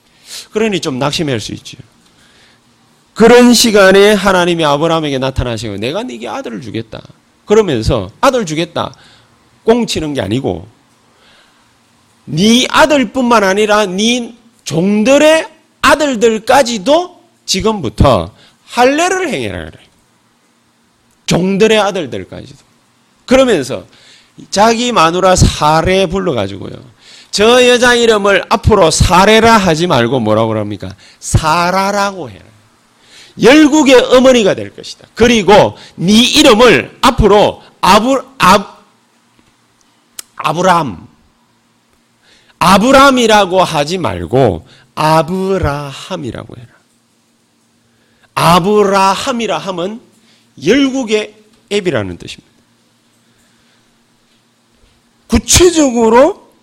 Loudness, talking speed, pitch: -10 LUFS, 220 characters per minute, 190 Hz